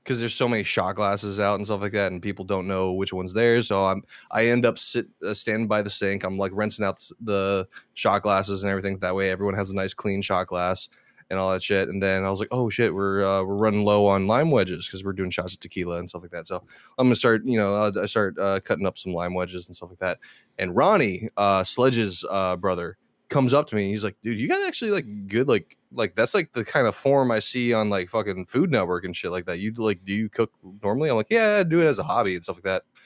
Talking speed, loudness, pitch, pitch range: 275 wpm, -24 LUFS, 100 Hz, 95-110 Hz